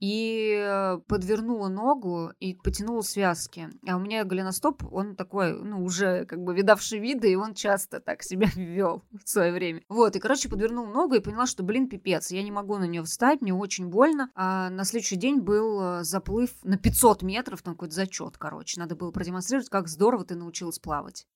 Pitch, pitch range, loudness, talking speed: 200 Hz, 185-220 Hz, -27 LUFS, 190 wpm